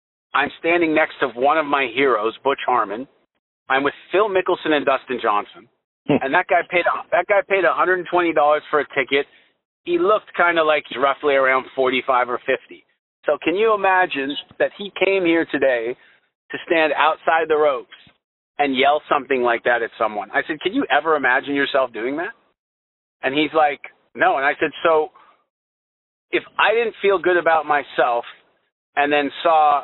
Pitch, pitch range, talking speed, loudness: 155 Hz, 135-180 Hz, 175 wpm, -19 LUFS